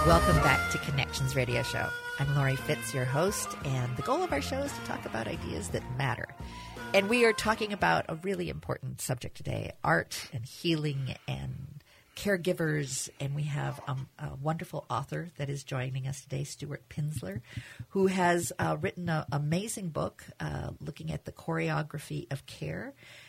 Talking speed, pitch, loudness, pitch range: 175 wpm, 145 Hz, -32 LUFS, 130-160 Hz